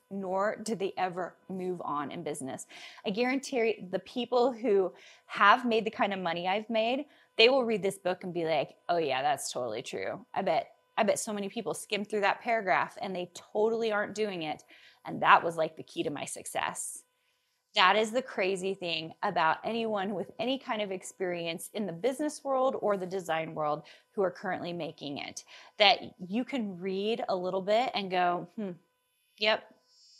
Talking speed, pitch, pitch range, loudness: 190 wpm, 205 Hz, 180-235 Hz, -30 LUFS